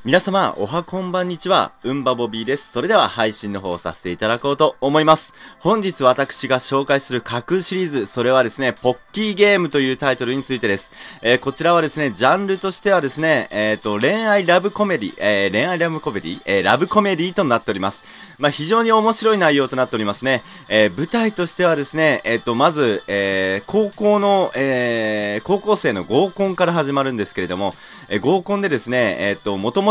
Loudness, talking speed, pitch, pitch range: -18 LUFS, 430 characters per minute, 145 Hz, 120-190 Hz